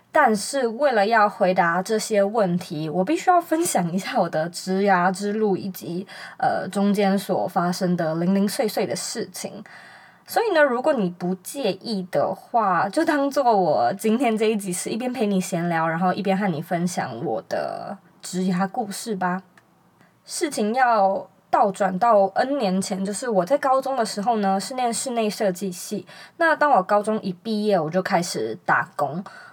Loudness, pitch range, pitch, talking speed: -22 LUFS, 185-225 Hz, 195 Hz, 250 characters per minute